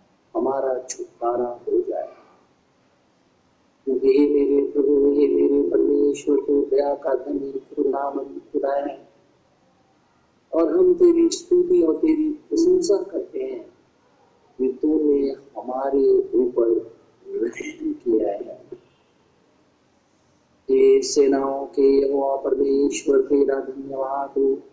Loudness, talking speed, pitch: -21 LUFS, 95 wpm, 310 Hz